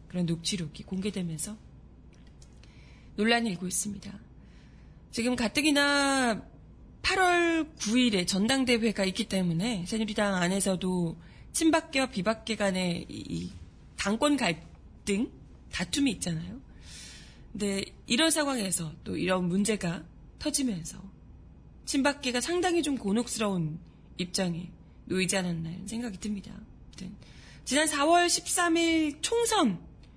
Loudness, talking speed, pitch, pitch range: -28 LUFS, 245 characters per minute, 210 Hz, 185-275 Hz